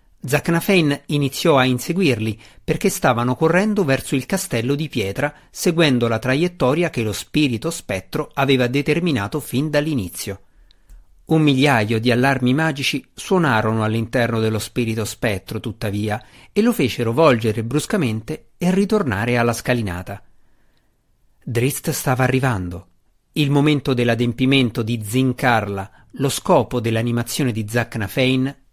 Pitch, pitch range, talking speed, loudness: 130 Hz, 115-150 Hz, 115 wpm, -19 LUFS